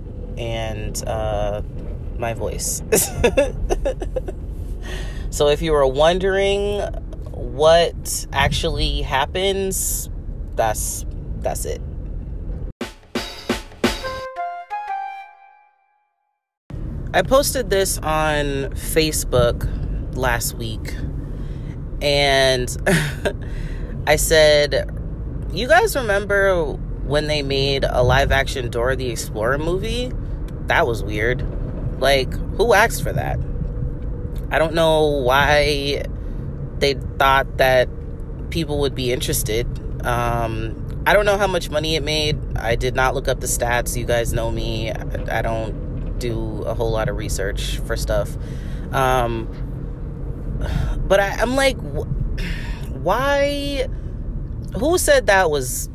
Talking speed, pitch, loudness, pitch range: 105 wpm, 130 Hz, -20 LUFS, 110-160 Hz